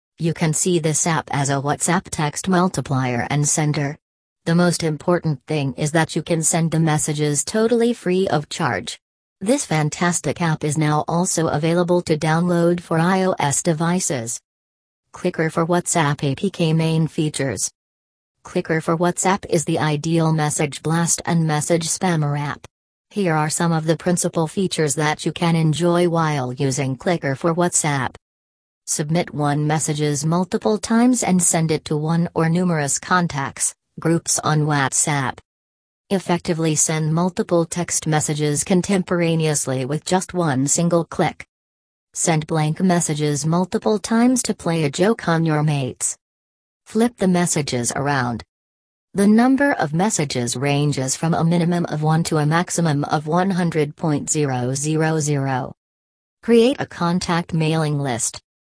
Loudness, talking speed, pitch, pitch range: -19 LUFS, 140 wpm, 160 Hz, 145-175 Hz